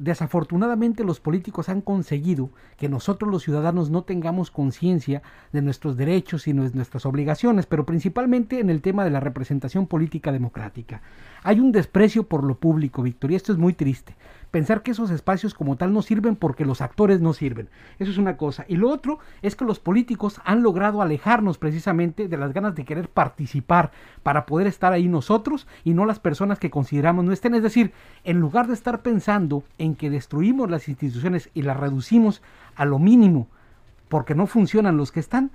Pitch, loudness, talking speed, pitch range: 170 Hz, -22 LUFS, 190 wpm, 145-205 Hz